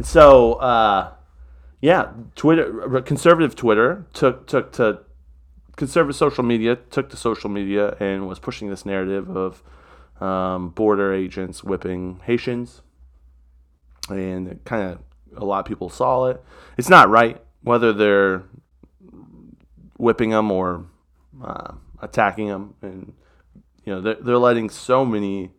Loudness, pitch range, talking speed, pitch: -19 LUFS, 90-115 Hz, 125 wpm, 100 Hz